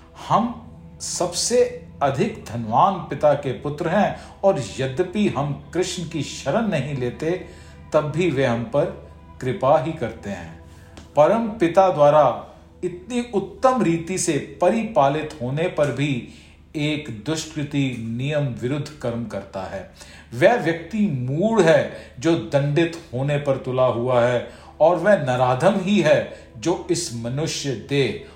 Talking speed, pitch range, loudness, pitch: 125 wpm, 125-175 Hz, -21 LUFS, 150 Hz